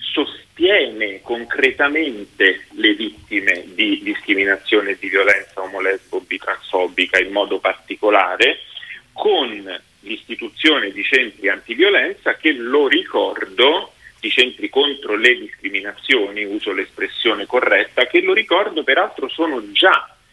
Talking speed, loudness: 105 wpm, -17 LUFS